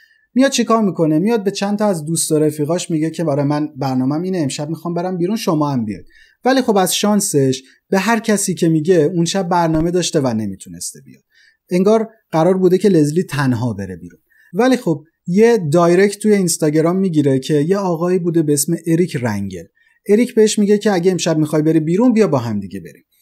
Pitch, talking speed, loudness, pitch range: 170 Hz, 200 wpm, -16 LUFS, 150-200 Hz